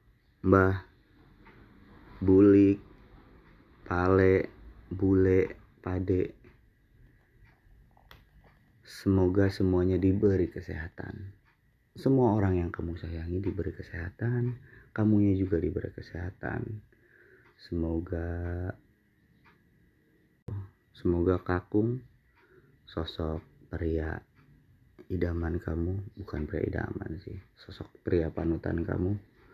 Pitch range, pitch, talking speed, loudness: 90-110 Hz, 95 Hz, 70 wpm, -29 LUFS